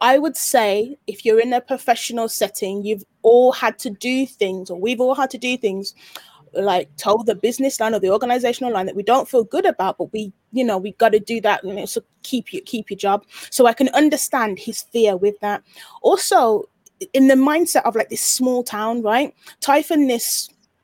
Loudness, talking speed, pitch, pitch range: -19 LUFS, 215 wpm, 235 Hz, 210-265 Hz